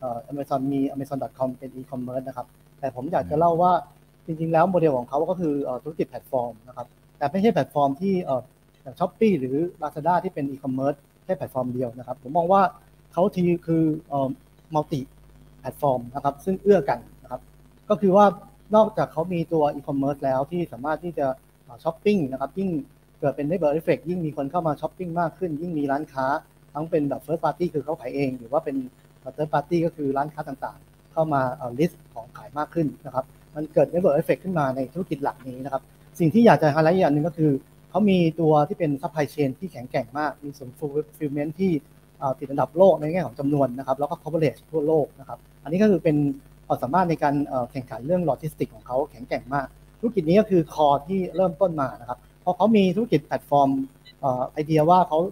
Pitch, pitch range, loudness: 150 Hz, 135-170 Hz, -24 LUFS